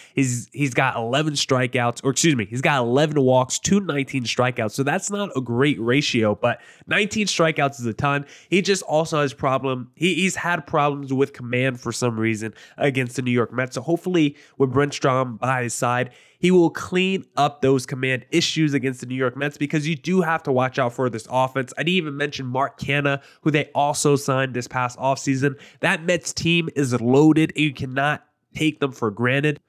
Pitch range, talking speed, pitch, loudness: 130-155 Hz, 200 wpm, 140 Hz, -21 LUFS